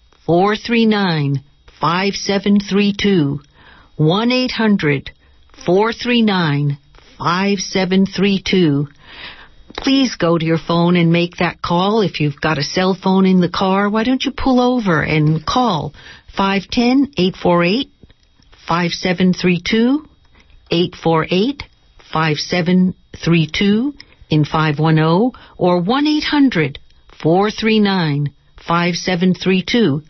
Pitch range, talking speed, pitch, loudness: 160-205 Hz, 70 wpm, 185 Hz, -16 LUFS